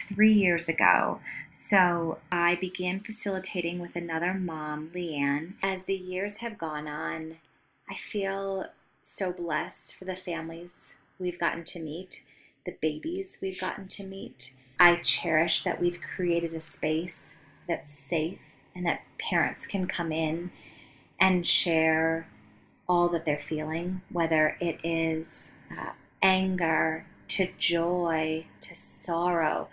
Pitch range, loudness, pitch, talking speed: 160-185 Hz, -26 LUFS, 170 Hz, 130 wpm